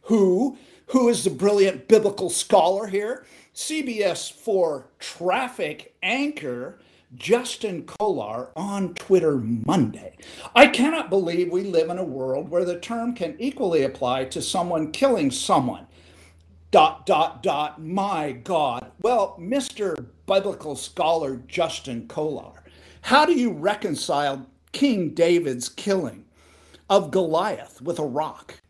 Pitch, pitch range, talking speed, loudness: 180 Hz, 150-215 Hz, 120 wpm, -23 LUFS